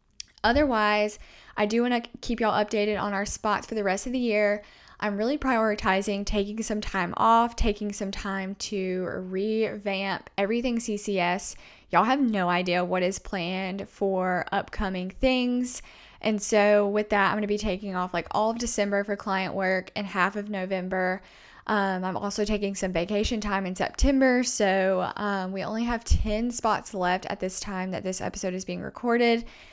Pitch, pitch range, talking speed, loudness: 205 Hz, 190-220 Hz, 180 wpm, -27 LUFS